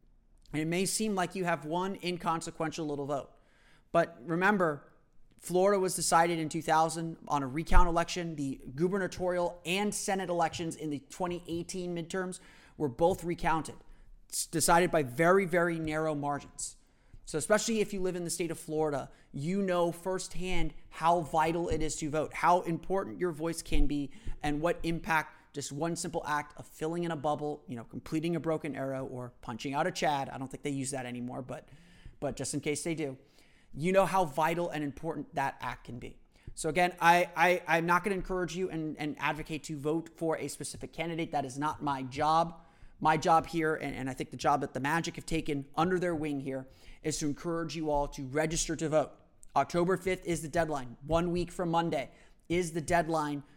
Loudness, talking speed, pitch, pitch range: -32 LUFS, 195 wpm, 160 Hz, 150-175 Hz